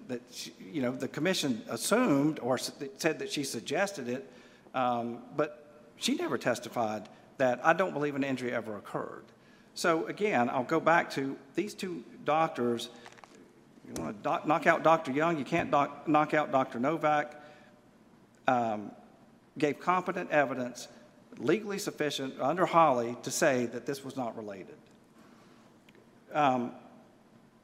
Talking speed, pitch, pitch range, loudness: 135 wpm, 145 Hz, 125-160 Hz, -31 LUFS